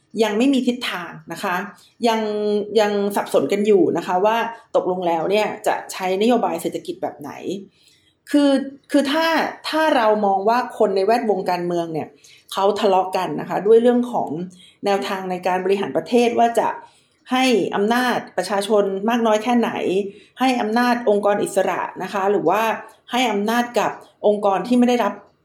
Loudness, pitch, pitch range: -20 LUFS, 215 Hz, 195-240 Hz